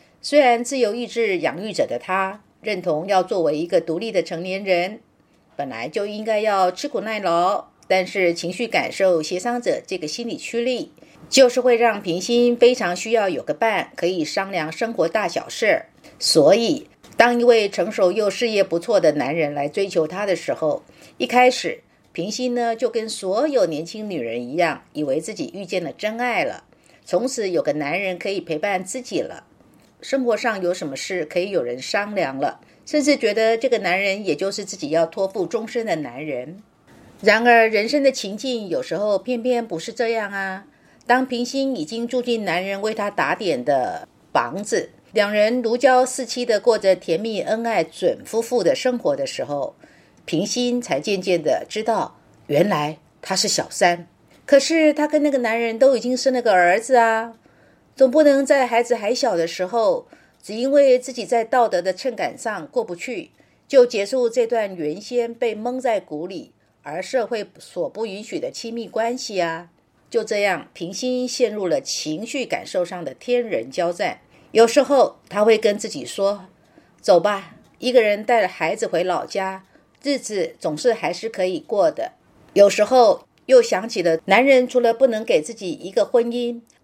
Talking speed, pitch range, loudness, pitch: 260 characters per minute, 185-245 Hz, -20 LUFS, 220 Hz